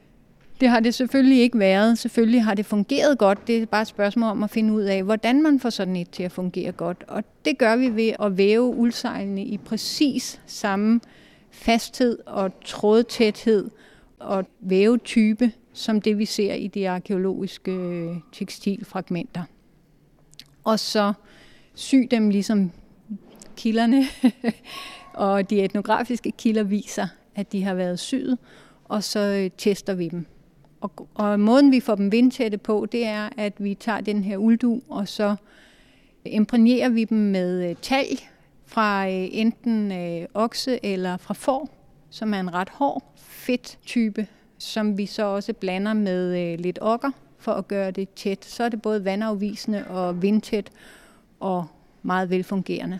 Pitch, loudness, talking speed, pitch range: 210 Hz, -23 LUFS, 150 wpm, 195-230 Hz